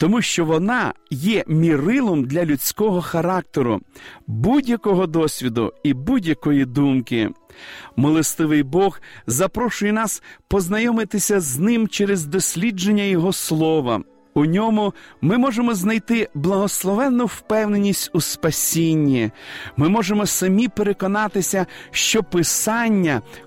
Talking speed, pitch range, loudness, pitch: 100 wpm, 155-215 Hz, -19 LUFS, 190 Hz